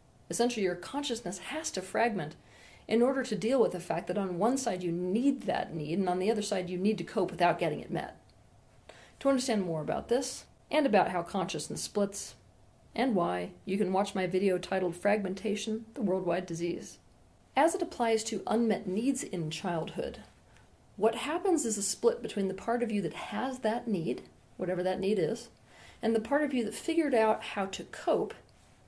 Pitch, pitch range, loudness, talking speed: 205 Hz, 180-230 Hz, -31 LUFS, 195 wpm